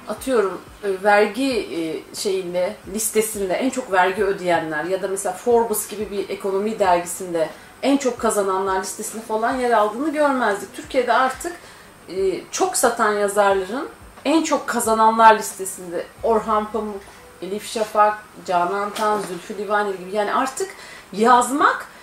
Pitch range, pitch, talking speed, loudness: 195-245 Hz, 215 Hz, 125 wpm, -20 LUFS